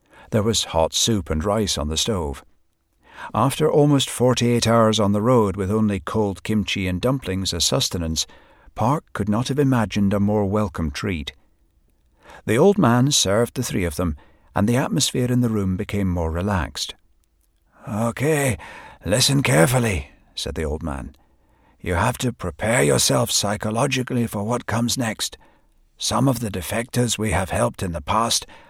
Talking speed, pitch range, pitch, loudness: 165 wpm, 85-120 Hz, 105 Hz, -21 LUFS